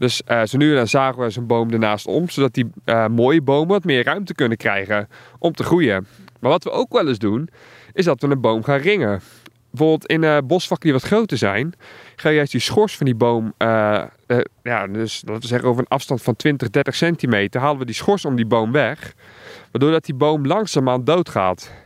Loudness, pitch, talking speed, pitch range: -19 LUFS, 130 Hz, 230 wpm, 115-150 Hz